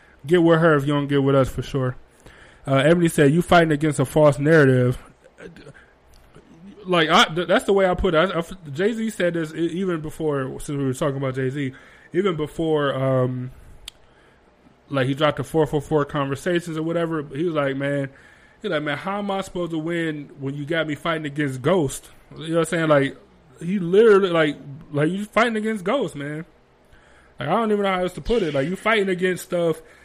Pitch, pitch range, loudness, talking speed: 160 Hz, 140-180 Hz, -21 LUFS, 210 wpm